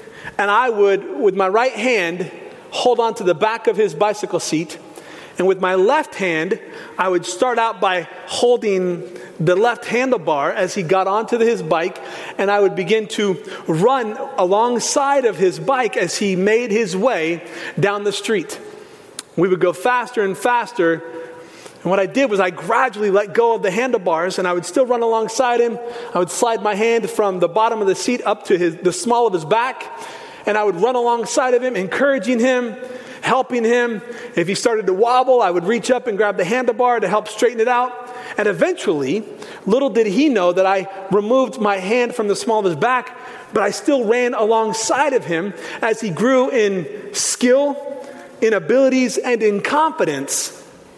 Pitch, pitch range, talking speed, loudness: 230 Hz, 195-255 Hz, 190 wpm, -18 LUFS